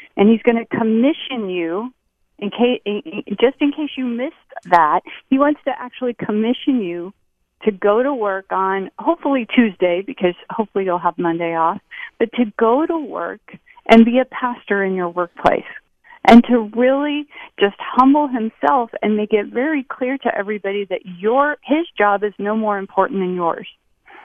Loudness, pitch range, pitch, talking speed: -18 LUFS, 200-260 Hz, 230 Hz, 170 wpm